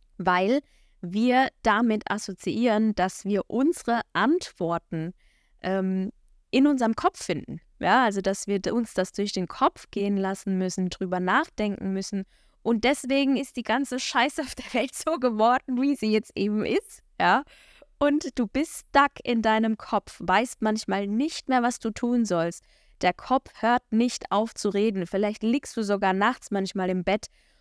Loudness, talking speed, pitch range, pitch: -26 LUFS, 165 wpm, 195-255 Hz, 220 Hz